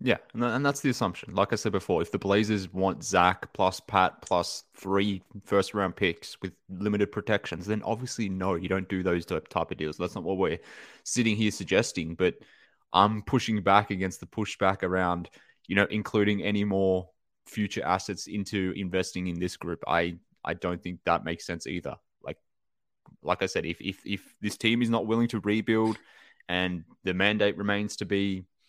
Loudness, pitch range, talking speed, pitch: -28 LUFS, 90-105 Hz, 185 wpm, 100 Hz